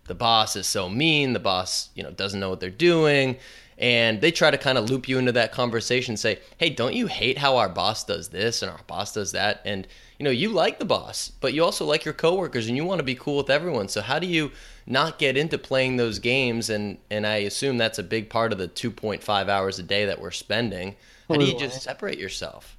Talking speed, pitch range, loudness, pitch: 250 wpm, 105-135 Hz, -24 LUFS, 120 Hz